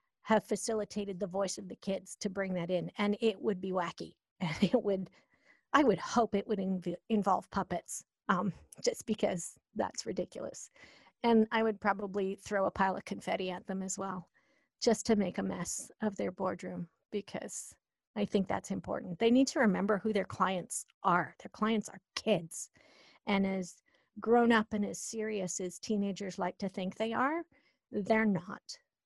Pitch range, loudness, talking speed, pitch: 190-220 Hz, -34 LUFS, 180 wpm, 200 Hz